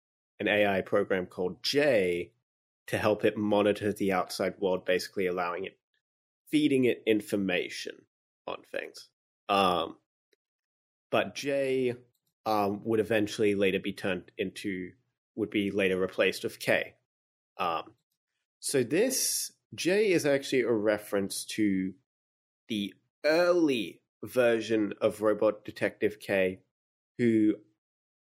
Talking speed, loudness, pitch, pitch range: 110 wpm, -29 LUFS, 105 Hz, 100-120 Hz